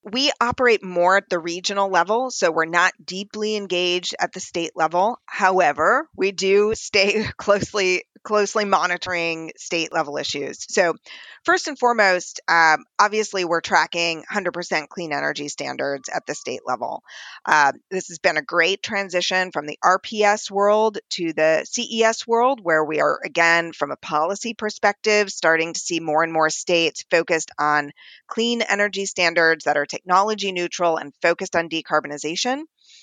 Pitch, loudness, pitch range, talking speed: 185 Hz, -20 LUFS, 165-210 Hz, 155 wpm